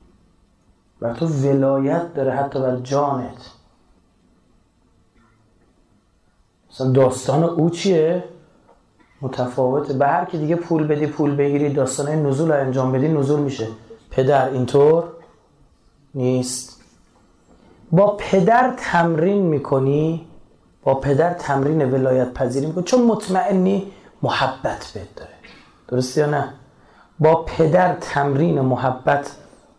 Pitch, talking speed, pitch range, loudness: 140 Hz, 105 wpm, 130-165 Hz, -19 LUFS